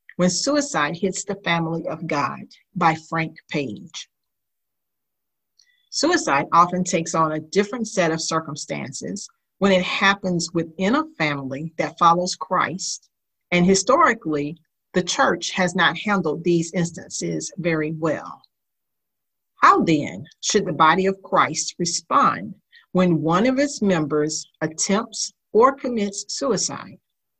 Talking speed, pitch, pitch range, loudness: 125 wpm, 180 Hz, 160-200 Hz, -21 LUFS